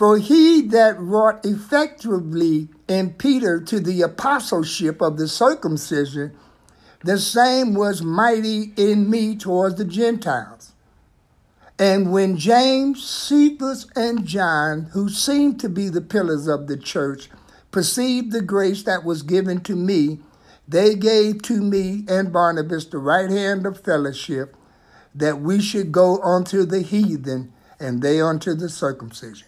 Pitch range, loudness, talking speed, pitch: 160-220 Hz, -19 LUFS, 140 wpm, 195 Hz